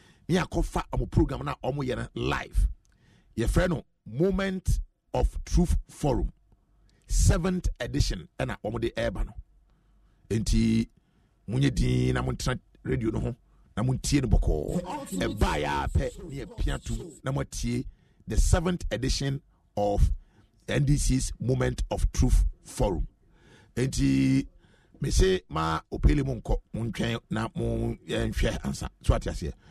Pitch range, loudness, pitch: 95-130 Hz, -29 LUFS, 115 Hz